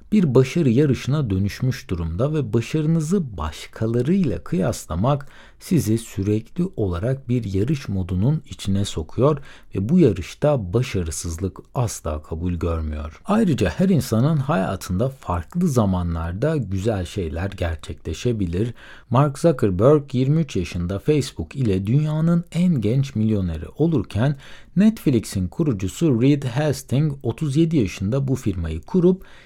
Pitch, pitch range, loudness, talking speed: 120 Hz, 95-150 Hz, -22 LUFS, 110 wpm